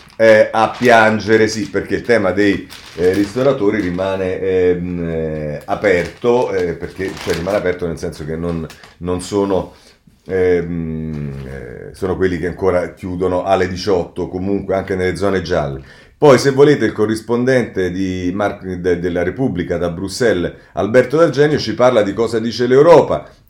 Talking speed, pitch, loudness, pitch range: 150 wpm, 95 Hz, -16 LUFS, 90-110 Hz